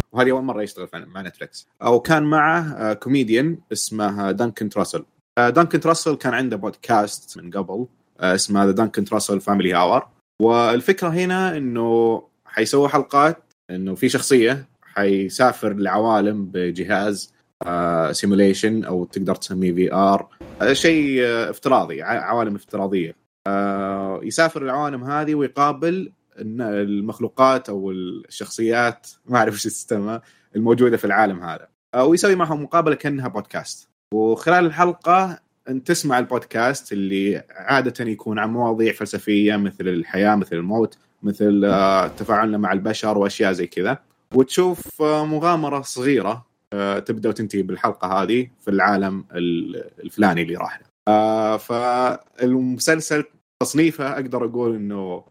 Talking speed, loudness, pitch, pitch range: 115 wpm, -20 LUFS, 115 Hz, 100-135 Hz